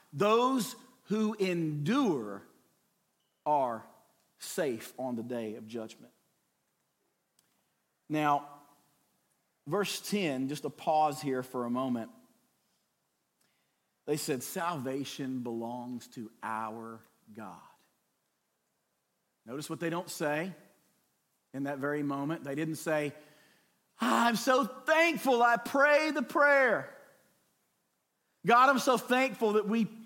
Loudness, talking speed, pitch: -30 LUFS, 105 wpm, 155 Hz